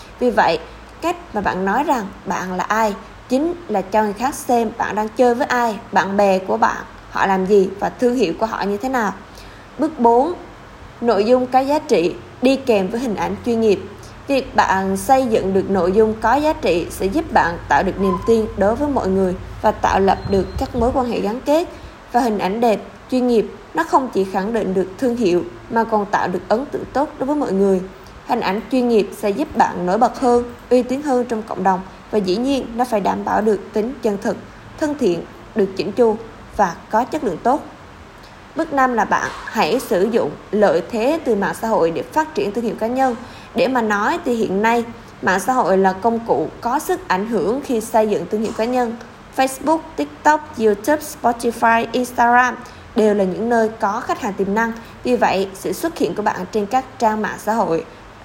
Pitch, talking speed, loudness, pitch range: 225 Hz, 220 wpm, -18 LUFS, 200-255 Hz